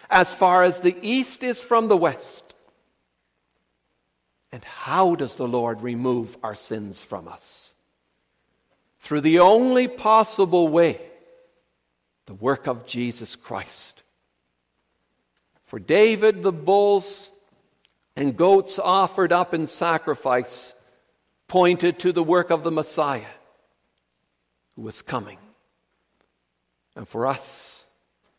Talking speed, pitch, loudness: 110 wpm, 155 Hz, -21 LUFS